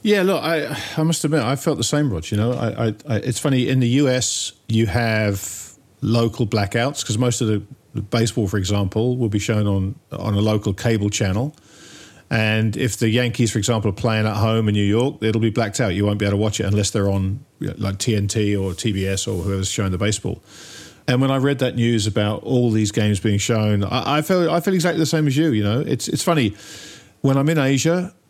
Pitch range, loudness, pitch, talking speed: 105-135 Hz, -20 LUFS, 115 Hz, 235 wpm